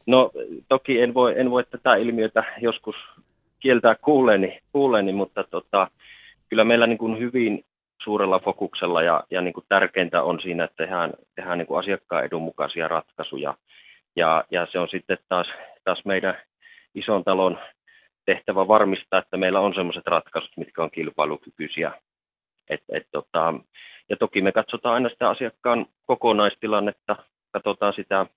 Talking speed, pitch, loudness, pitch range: 145 wpm, 115 Hz, -23 LUFS, 105-125 Hz